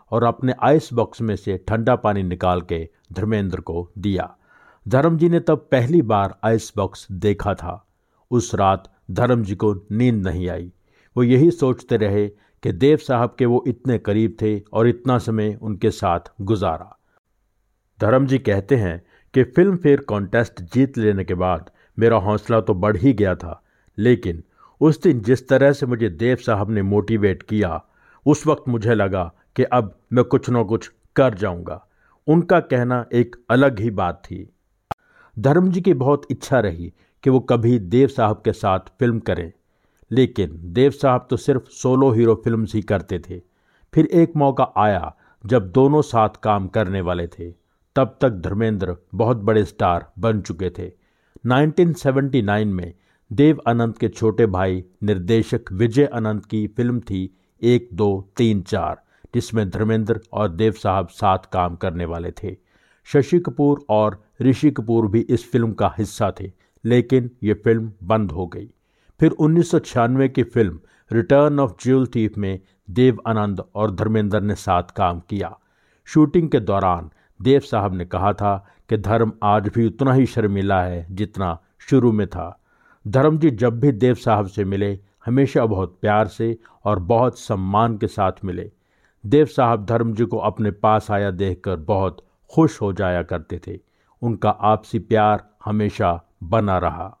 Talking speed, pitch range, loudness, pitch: 165 wpm, 95-125 Hz, -20 LUFS, 110 Hz